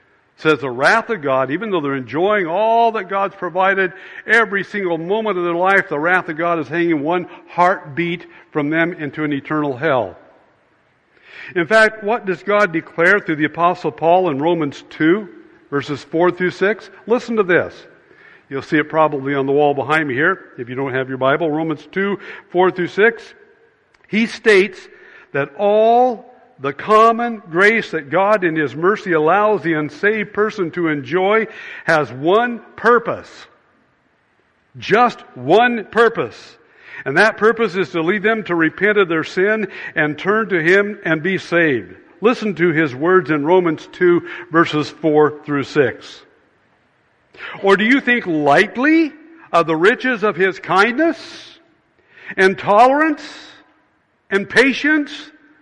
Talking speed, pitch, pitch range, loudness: 155 wpm, 185 Hz, 160-225 Hz, -16 LUFS